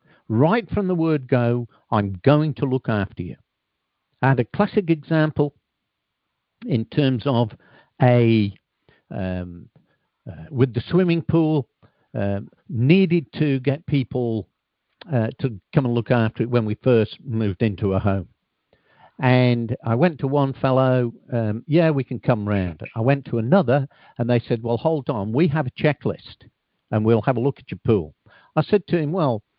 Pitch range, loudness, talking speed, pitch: 115-145 Hz, -21 LUFS, 170 wpm, 125 Hz